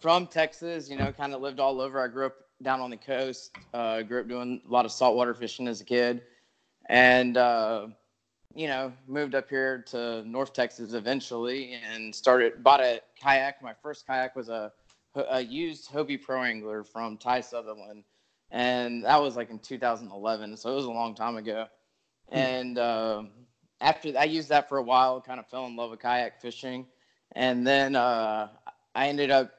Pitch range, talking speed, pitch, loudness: 115-135 Hz, 190 wpm, 125 Hz, -28 LUFS